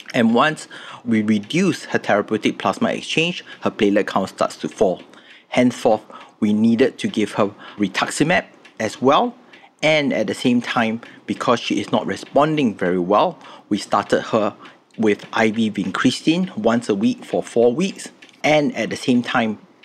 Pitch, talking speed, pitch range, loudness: 120 Hz, 155 wpm, 110-175 Hz, -19 LUFS